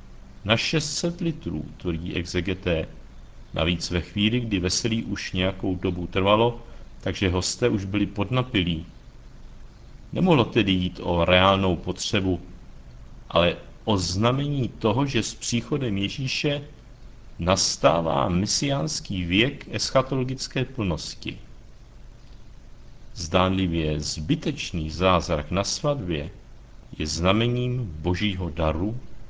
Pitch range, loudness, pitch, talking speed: 90-120 Hz, -24 LUFS, 95 Hz, 95 wpm